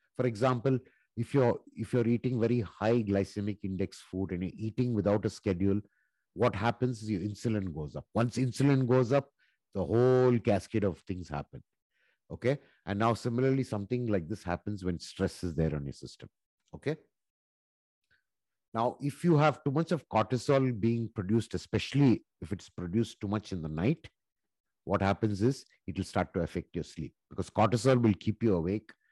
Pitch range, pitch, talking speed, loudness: 95-125 Hz, 110 Hz, 175 wpm, -31 LUFS